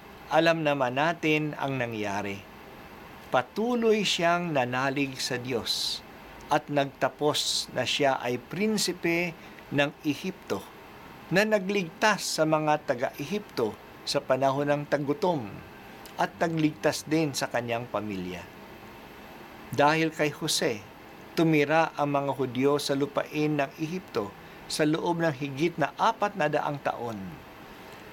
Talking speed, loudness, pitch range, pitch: 115 wpm, -28 LUFS, 140-170 Hz, 150 Hz